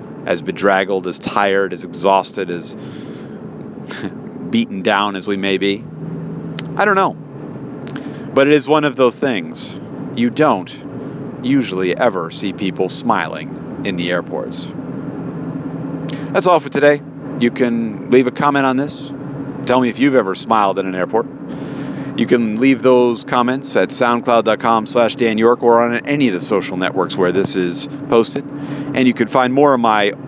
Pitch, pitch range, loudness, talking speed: 120 Hz, 100-140 Hz, -16 LUFS, 160 wpm